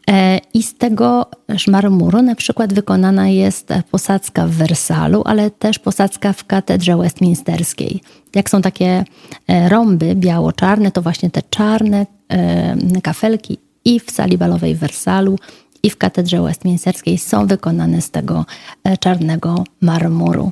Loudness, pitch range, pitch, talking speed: -15 LUFS, 170-205 Hz, 190 Hz, 125 wpm